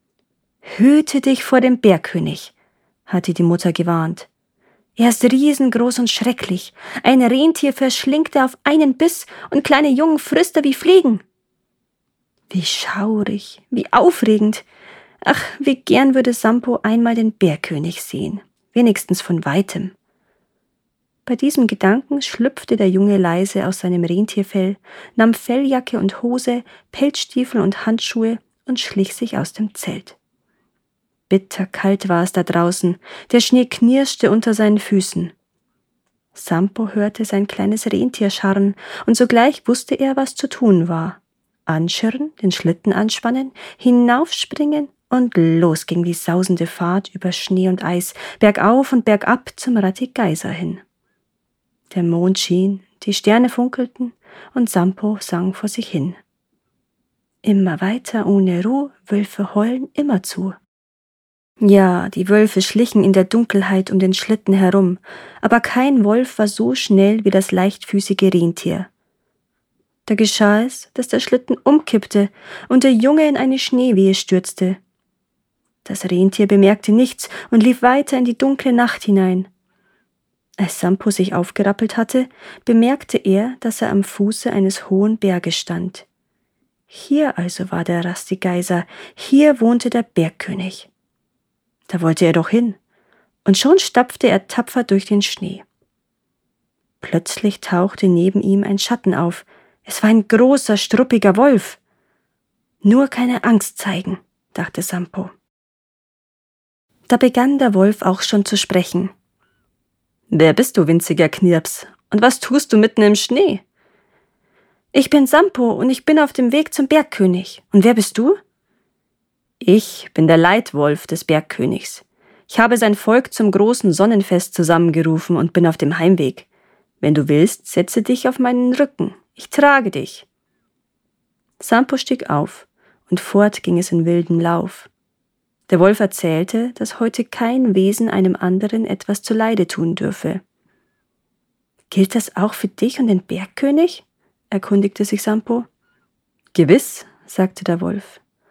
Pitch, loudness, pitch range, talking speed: 205 Hz, -16 LUFS, 185-245 Hz, 135 wpm